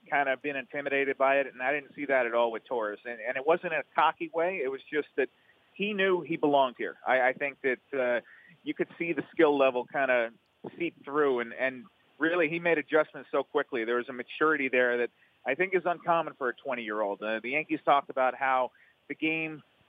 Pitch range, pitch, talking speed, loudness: 130-165 Hz, 145 Hz, 235 wpm, -29 LUFS